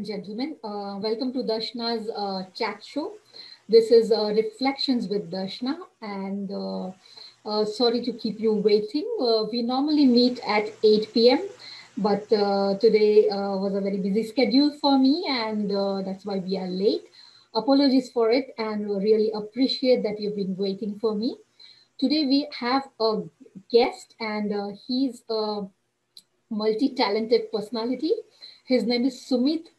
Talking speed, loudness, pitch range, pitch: 150 wpm, -24 LUFS, 210-255 Hz, 225 Hz